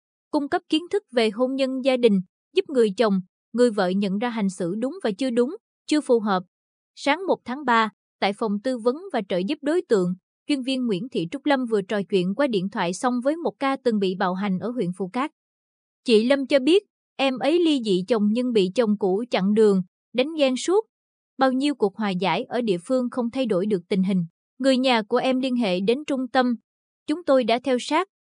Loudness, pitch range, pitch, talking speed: -23 LUFS, 205-270 Hz, 245 Hz, 230 wpm